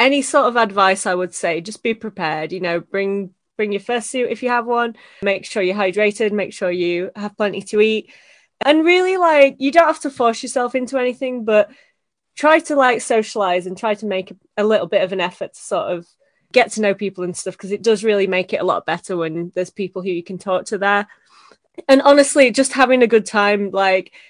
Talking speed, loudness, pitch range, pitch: 230 wpm, -17 LUFS, 190-250 Hz, 210 Hz